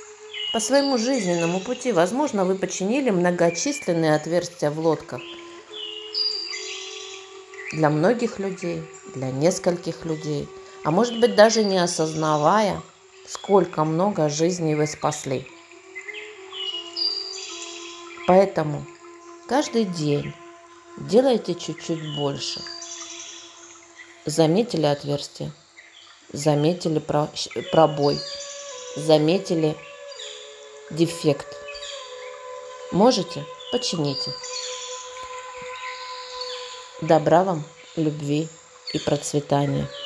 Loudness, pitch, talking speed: -23 LUFS, 195 Hz, 70 wpm